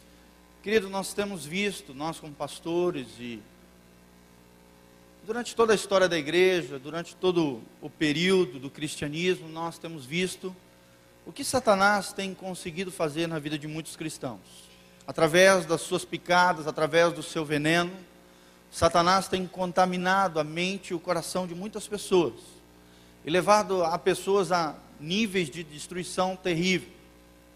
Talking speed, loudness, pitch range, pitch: 135 wpm, -27 LUFS, 140-185 Hz, 170 Hz